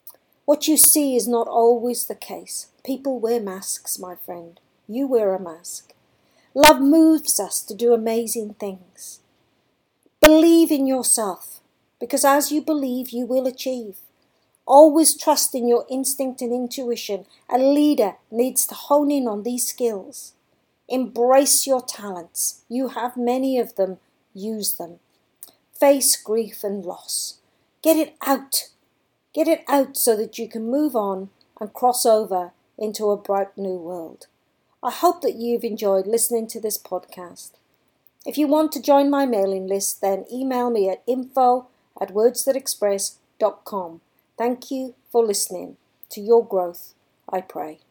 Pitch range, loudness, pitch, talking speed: 205-270 Hz, -20 LUFS, 240 Hz, 145 wpm